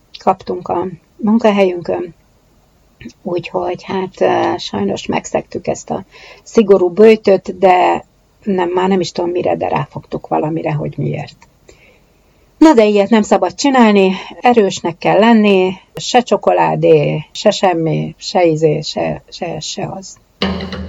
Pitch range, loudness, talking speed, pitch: 175-210 Hz, -14 LUFS, 120 wpm, 185 Hz